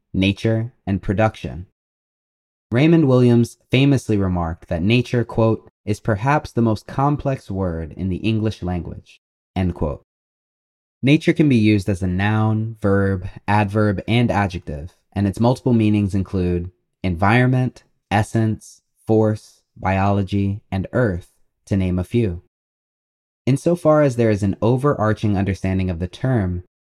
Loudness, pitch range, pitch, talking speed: -19 LUFS, 95-120 Hz, 105 Hz, 130 wpm